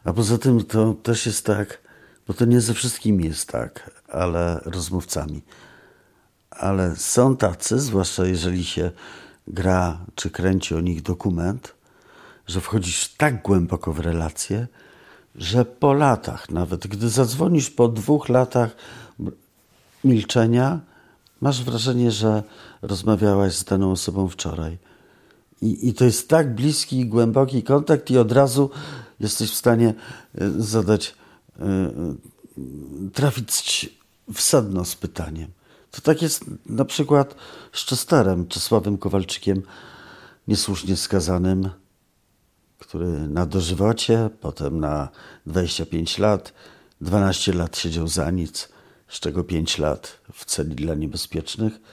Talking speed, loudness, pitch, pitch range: 120 wpm, -22 LUFS, 100 Hz, 90-120 Hz